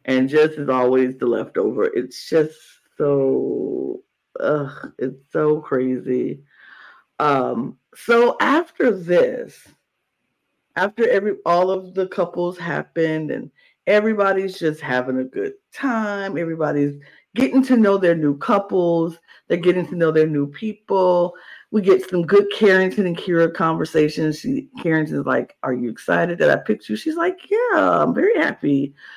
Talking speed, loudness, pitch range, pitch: 145 wpm, -20 LUFS, 150-215 Hz, 175 Hz